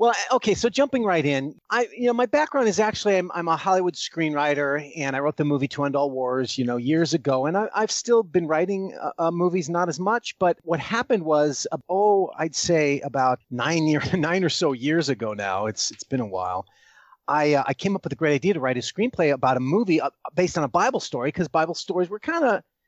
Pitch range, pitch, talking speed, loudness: 145-195 Hz, 165 Hz, 235 wpm, -23 LUFS